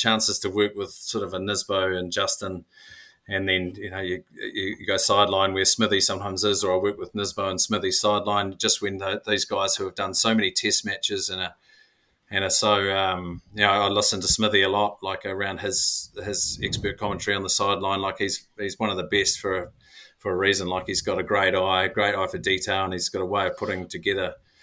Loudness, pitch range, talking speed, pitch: -23 LUFS, 95-105 Hz, 235 wpm, 100 Hz